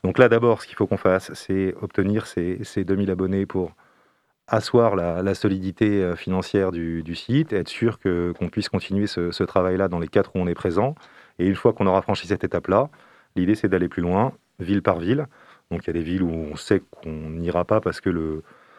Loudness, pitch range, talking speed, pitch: -23 LUFS, 85-100 Hz, 225 wpm, 95 Hz